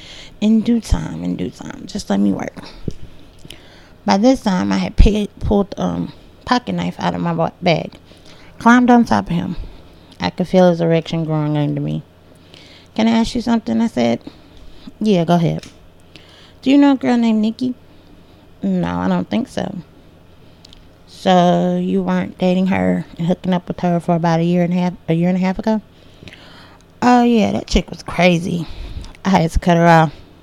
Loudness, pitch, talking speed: -17 LUFS, 175 Hz, 185 wpm